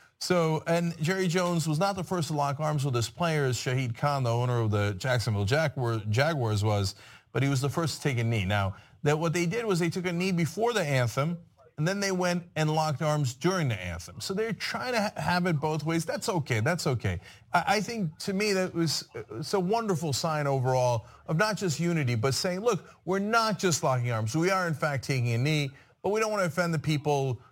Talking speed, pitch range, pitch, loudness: 230 wpm, 130-180 Hz, 155 Hz, -28 LUFS